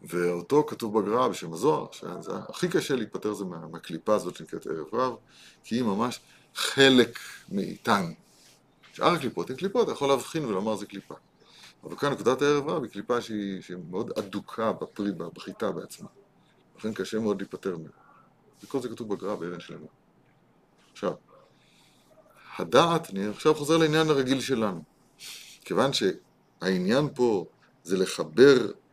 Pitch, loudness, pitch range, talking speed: 105 Hz, -27 LUFS, 95-135 Hz, 145 wpm